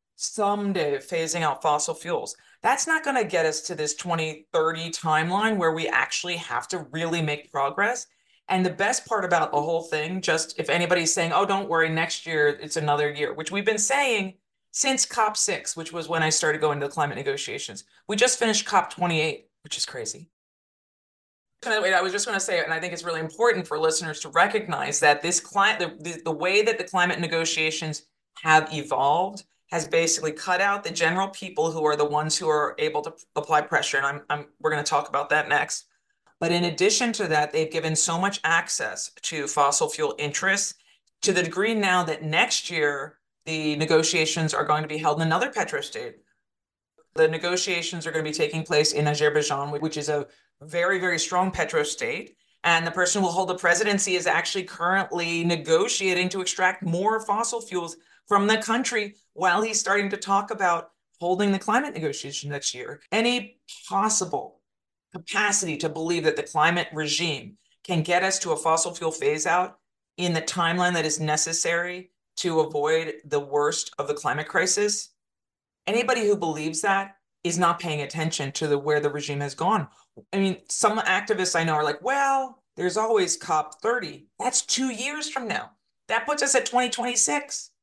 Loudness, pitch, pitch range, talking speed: -24 LUFS, 175 Hz, 155-205 Hz, 190 wpm